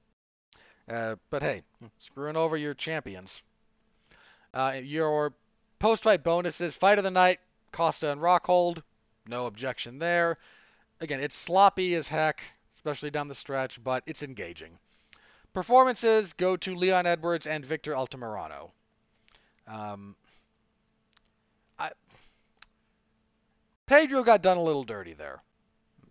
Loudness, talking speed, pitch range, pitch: -27 LUFS, 115 wpm, 135-180 Hz, 160 Hz